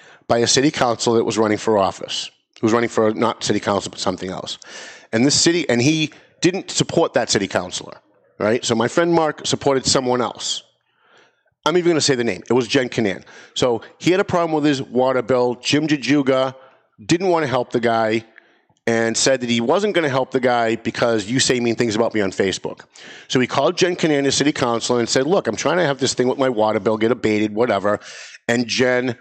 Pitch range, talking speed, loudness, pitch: 115-140 Hz, 225 wpm, -19 LUFS, 125 Hz